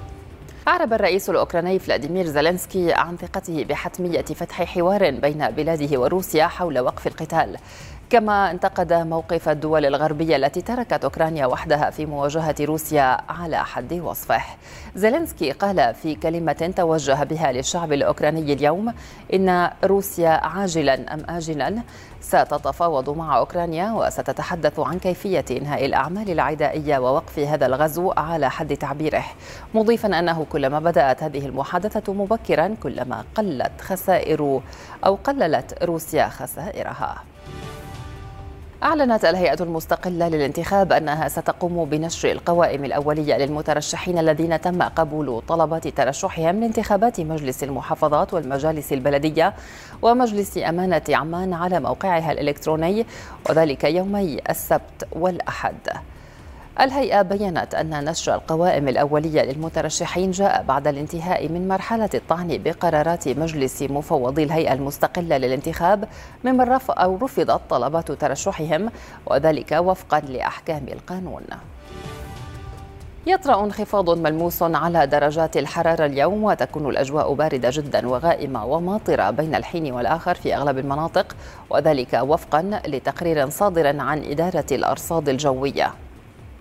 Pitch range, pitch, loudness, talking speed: 145-180 Hz, 160 Hz, -21 LUFS, 110 wpm